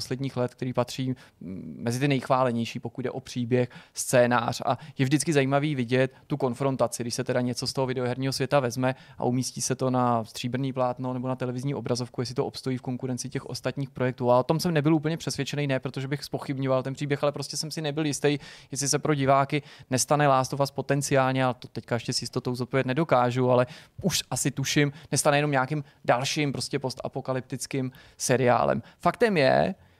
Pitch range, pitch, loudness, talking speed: 125-145 Hz, 130 Hz, -27 LUFS, 190 wpm